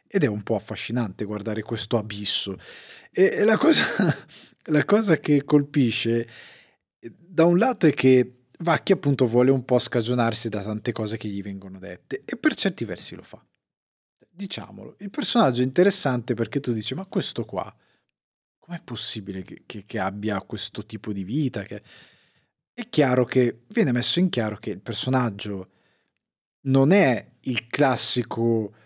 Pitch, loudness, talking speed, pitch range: 125 Hz, -23 LUFS, 155 wpm, 110-160 Hz